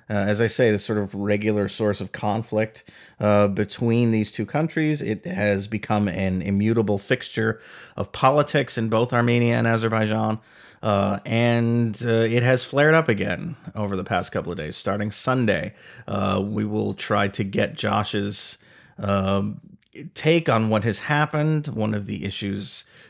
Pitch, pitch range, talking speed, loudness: 110 Hz, 100-120 Hz, 160 wpm, -23 LUFS